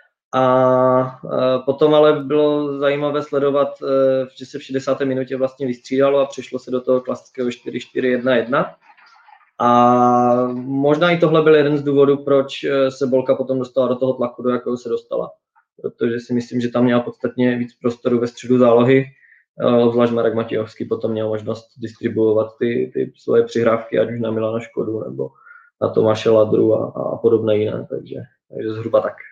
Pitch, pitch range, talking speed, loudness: 125 Hz, 120-135 Hz, 160 wpm, -18 LUFS